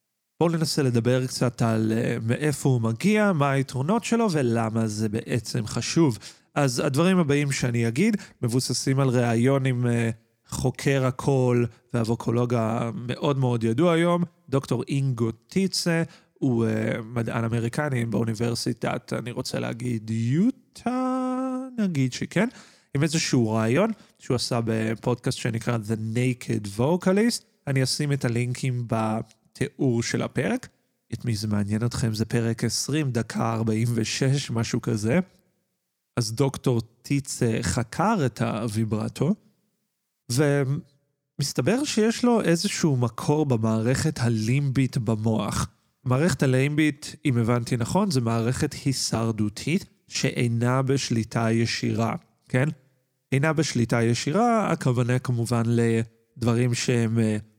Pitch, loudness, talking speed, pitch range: 125 Hz, -25 LUFS, 110 wpm, 115-150 Hz